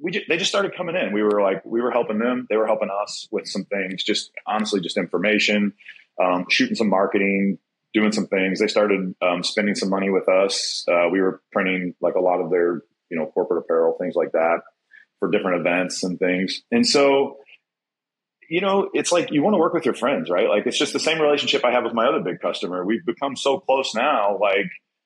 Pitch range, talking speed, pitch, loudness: 95-150 Hz, 225 wpm, 110 Hz, -21 LUFS